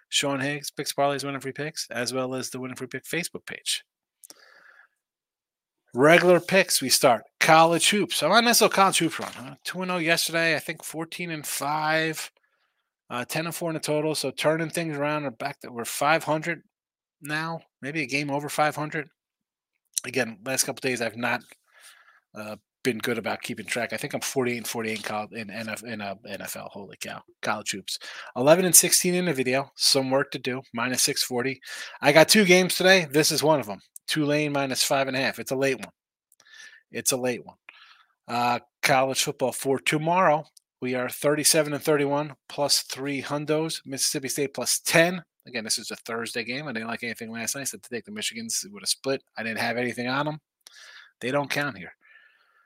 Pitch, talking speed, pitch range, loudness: 145 Hz, 190 wpm, 130-165 Hz, -24 LUFS